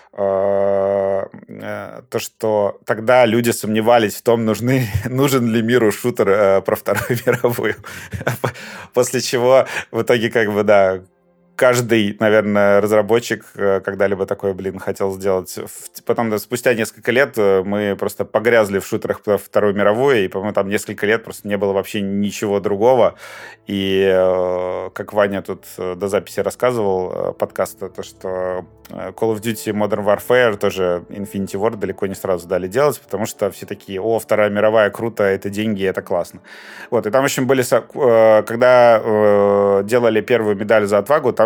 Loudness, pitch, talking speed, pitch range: -17 LUFS, 105 Hz, 150 wpm, 100-115 Hz